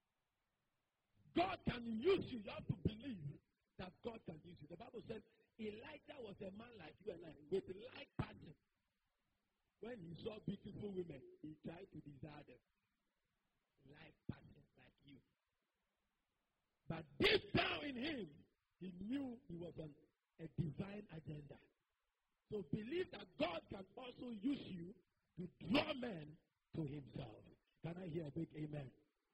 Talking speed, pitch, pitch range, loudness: 150 wpm, 180 Hz, 155-230 Hz, -47 LUFS